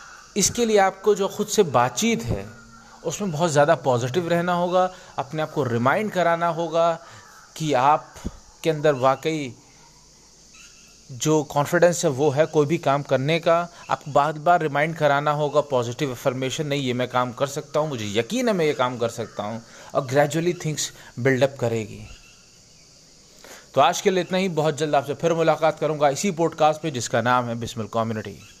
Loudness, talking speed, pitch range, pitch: -22 LUFS, 175 wpm, 125-170 Hz, 150 Hz